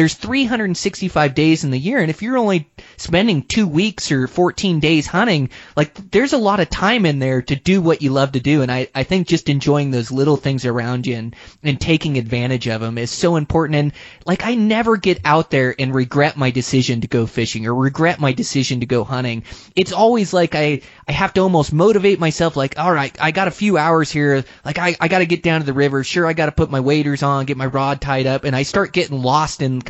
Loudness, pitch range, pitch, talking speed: -17 LUFS, 130-175 Hz, 150 Hz, 245 wpm